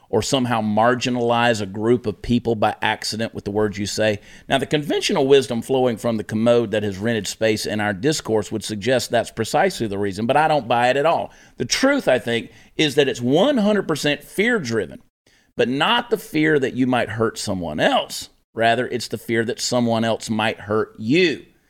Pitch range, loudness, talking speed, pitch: 110-140 Hz, -20 LUFS, 200 wpm, 115 Hz